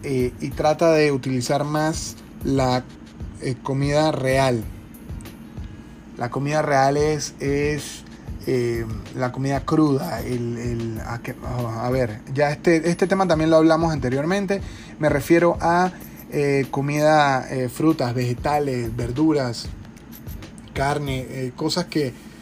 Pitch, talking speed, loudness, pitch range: 140 Hz, 125 wpm, -22 LUFS, 125-155 Hz